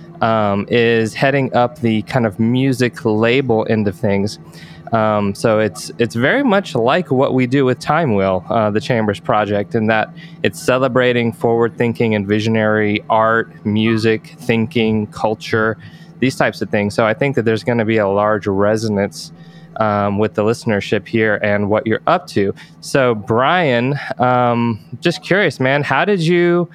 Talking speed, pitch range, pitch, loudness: 170 wpm, 110-130 Hz, 115 Hz, -16 LUFS